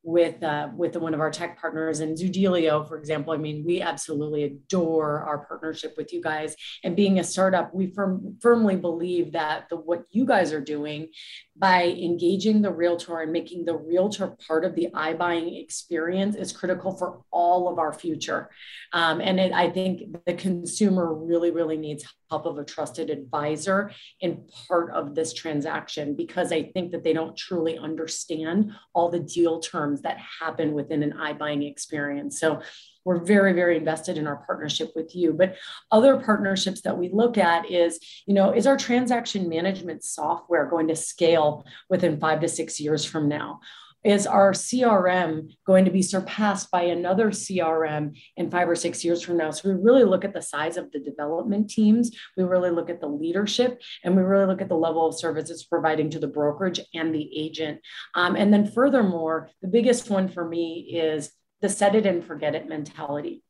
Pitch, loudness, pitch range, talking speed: 170 Hz, -24 LUFS, 155-190 Hz, 185 wpm